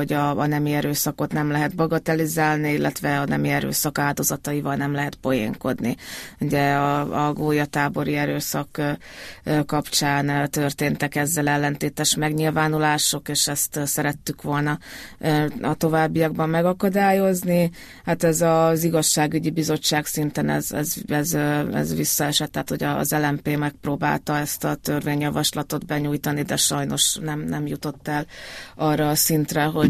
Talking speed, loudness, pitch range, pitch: 125 wpm, -22 LUFS, 145-155 Hz, 150 Hz